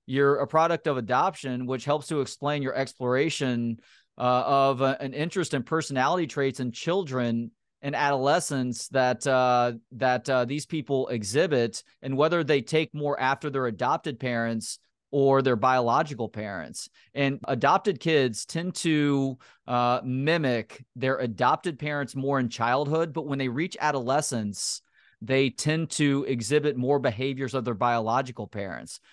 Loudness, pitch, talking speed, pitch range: -26 LUFS, 135 Hz, 145 wpm, 125-145 Hz